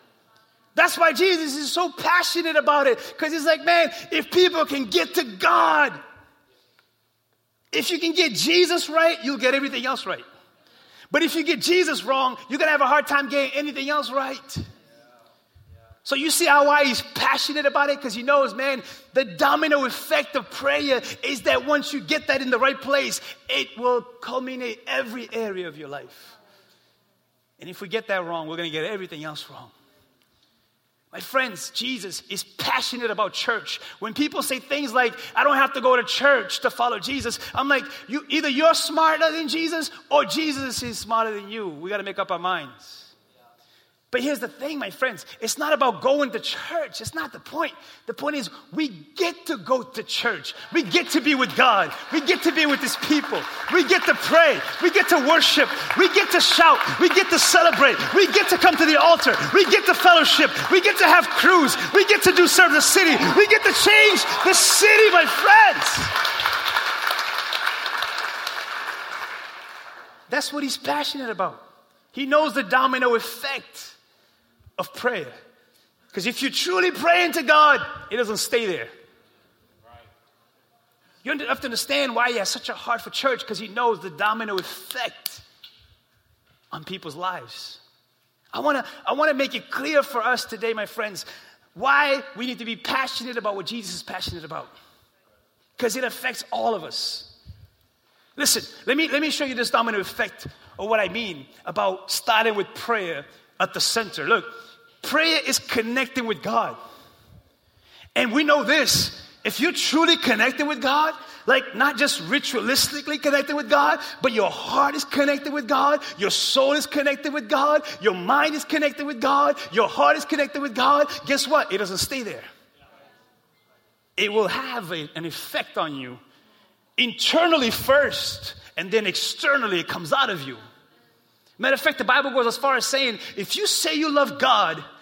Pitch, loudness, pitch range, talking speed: 280 Hz, -20 LUFS, 240-315 Hz, 180 wpm